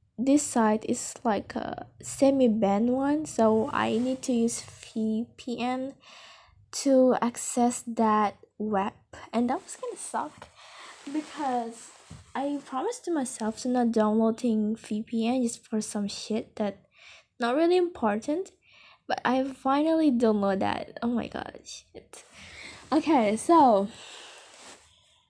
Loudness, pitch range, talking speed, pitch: -27 LUFS, 220-275 Hz, 120 wpm, 240 Hz